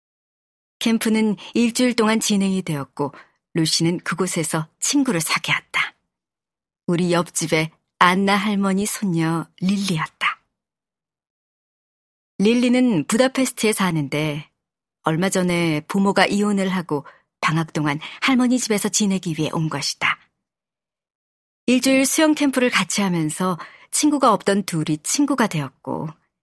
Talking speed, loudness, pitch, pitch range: 255 characters per minute, -20 LUFS, 190 Hz, 165-225 Hz